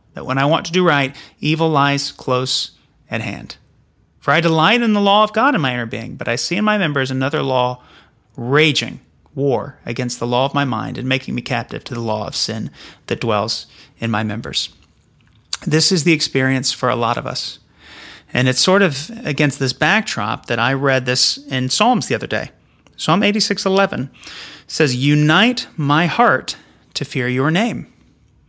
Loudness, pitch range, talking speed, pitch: -17 LUFS, 125-165 Hz, 190 wpm, 140 Hz